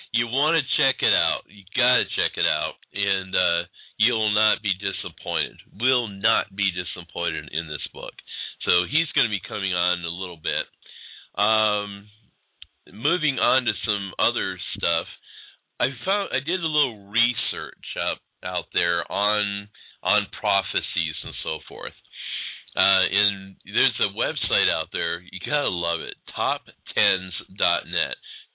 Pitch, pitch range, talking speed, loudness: 100 Hz, 95-110 Hz, 150 wpm, -24 LUFS